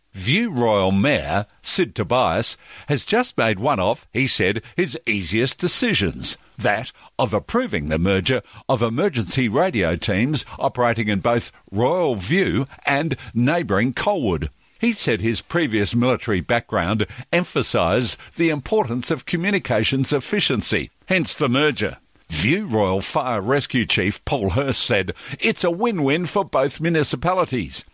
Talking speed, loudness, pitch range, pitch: 130 wpm, -21 LUFS, 110-165 Hz, 130 Hz